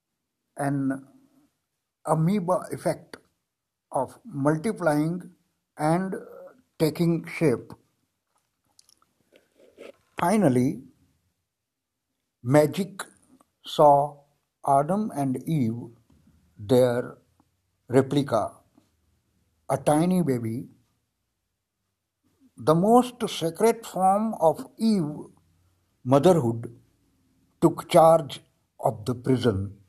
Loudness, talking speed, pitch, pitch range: -24 LUFS, 60 wpm, 140 Hz, 115-170 Hz